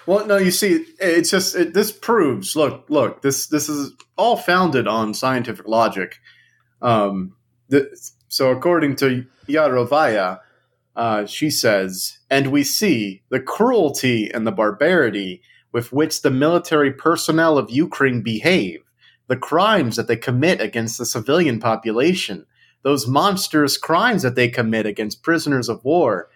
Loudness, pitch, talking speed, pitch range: -18 LUFS, 135 Hz, 145 wpm, 115-155 Hz